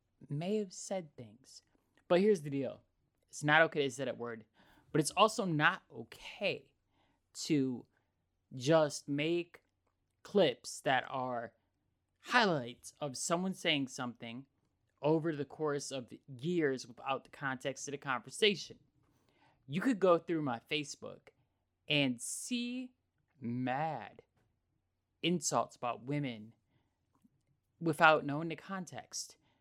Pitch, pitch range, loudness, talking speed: 135 Hz, 120-160 Hz, -35 LUFS, 120 wpm